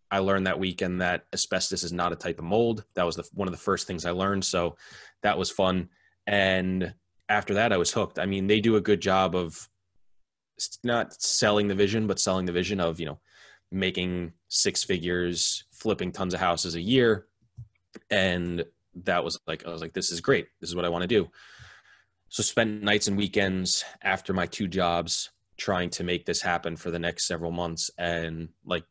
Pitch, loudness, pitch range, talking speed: 90 Hz, -27 LUFS, 85-100 Hz, 205 wpm